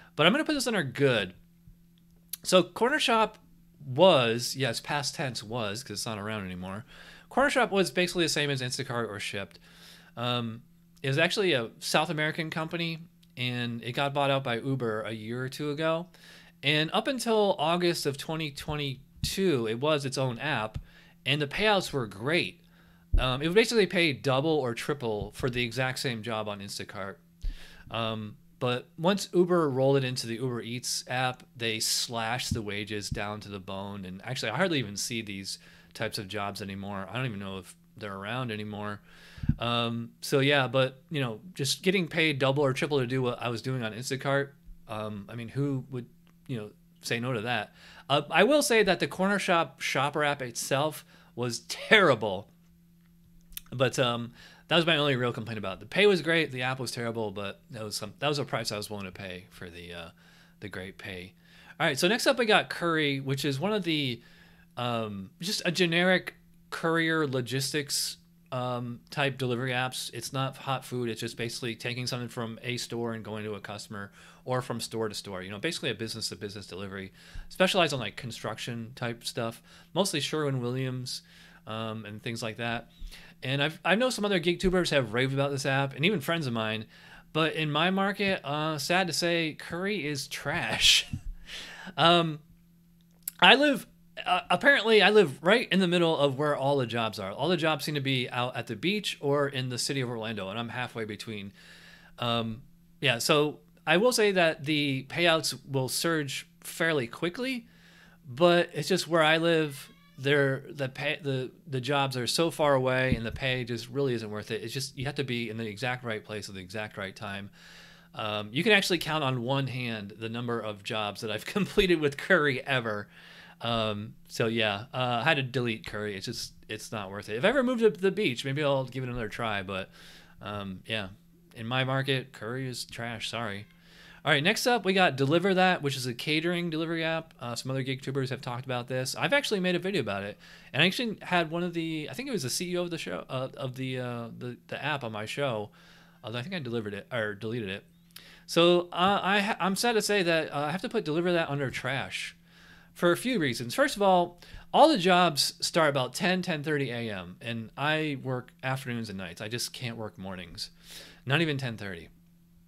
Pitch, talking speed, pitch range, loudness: 135 Hz, 205 wpm, 115-170 Hz, -28 LUFS